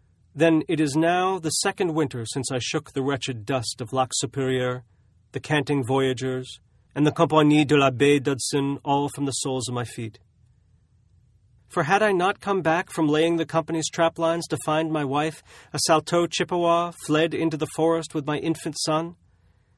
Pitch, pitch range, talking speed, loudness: 145 Hz, 125-165 Hz, 175 wpm, -23 LUFS